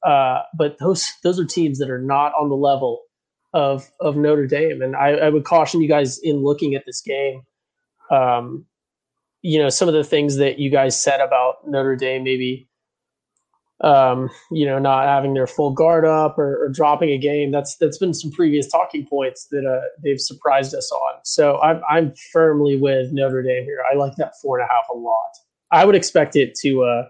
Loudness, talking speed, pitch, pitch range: -18 LUFS, 205 wpm, 140 Hz, 135-155 Hz